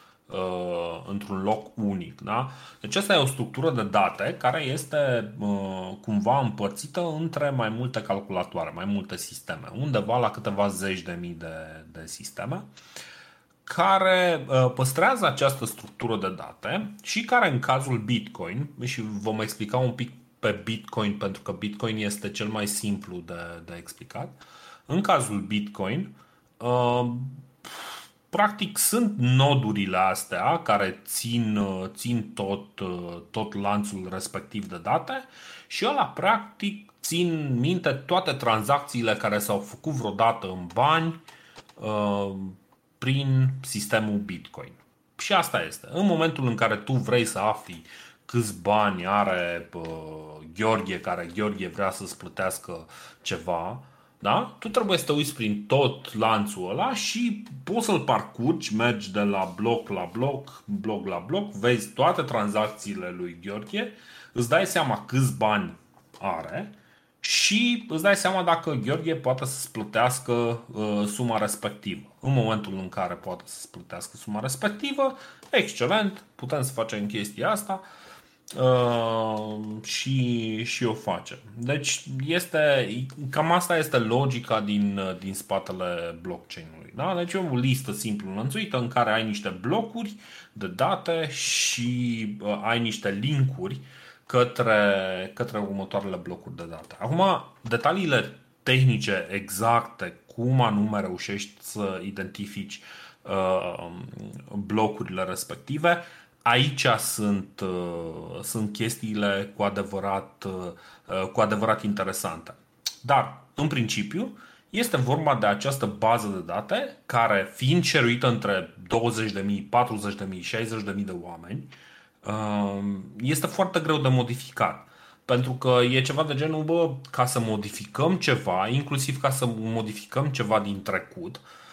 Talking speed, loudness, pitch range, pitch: 125 wpm, -26 LUFS, 100-140 Hz, 115 Hz